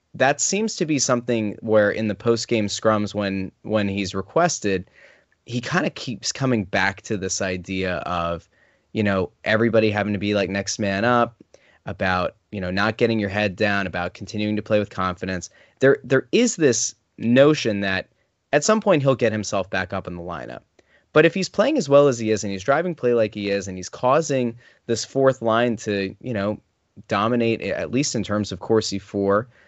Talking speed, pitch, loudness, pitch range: 200 wpm, 110 Hz, -22 LUFS, 100-120 Hz